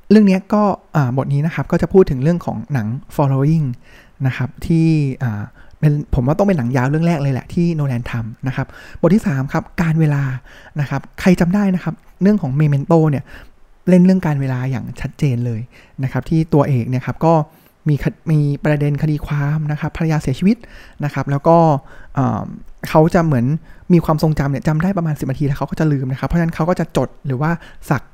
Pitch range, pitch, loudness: 135-165 Hz, 150 Hz, -17 LUFS